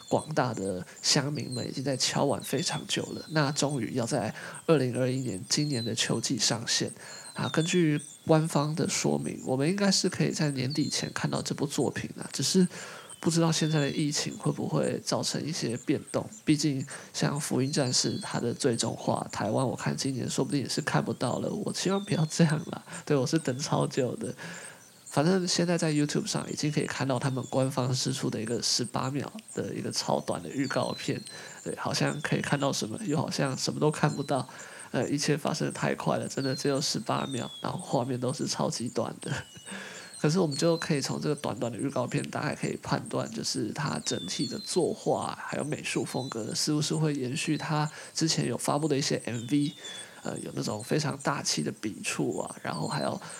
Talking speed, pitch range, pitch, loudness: 305 characters per minute, 135-165 Hz, 150 Hz, -29 LUFS